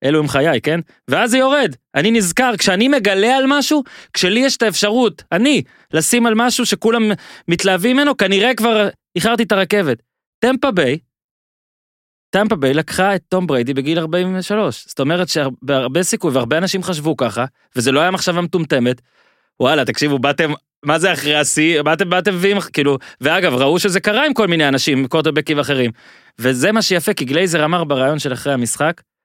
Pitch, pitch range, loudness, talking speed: 180 Hz, 150-215 Hz, -16 LUFS, 170 wpm